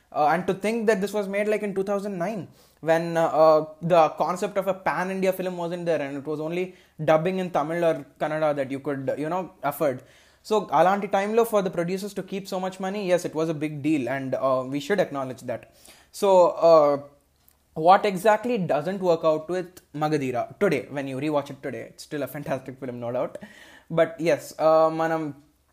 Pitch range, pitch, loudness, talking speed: 150-190 Hz, 165 Hz, -24 LUFS, 210 wpm